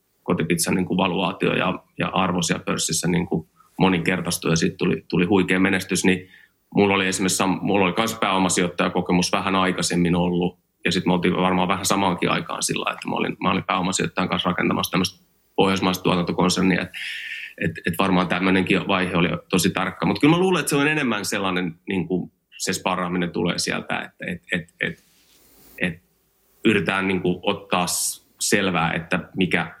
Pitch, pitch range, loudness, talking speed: 90 Hz, 90-95 Hz, -22 LUFS, 170 wpm